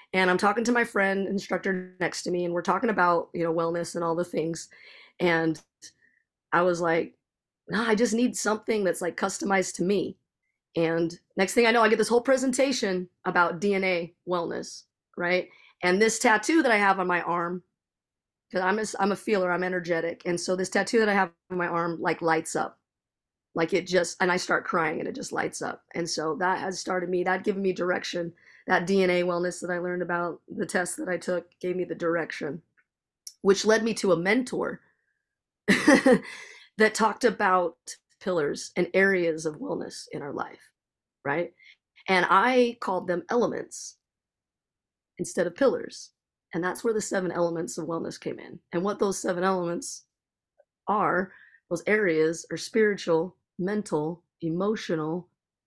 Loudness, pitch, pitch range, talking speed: -26 LUFS, 180 Hz, 170-205 Hz, 180 wpm